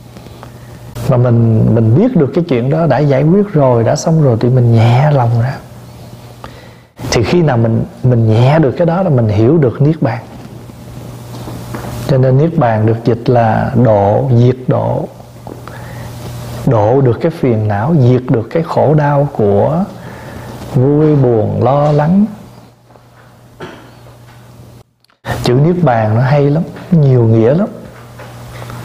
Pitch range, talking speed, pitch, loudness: 115-145 Hz, 145 wpm, 125 Hz, -11 LUFS